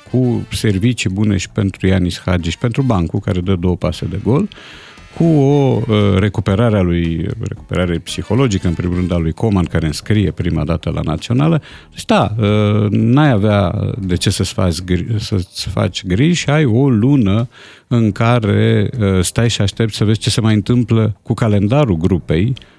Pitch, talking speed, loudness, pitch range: 105 Hz, 170 wpm, -15 LUFS, 90-115 Hz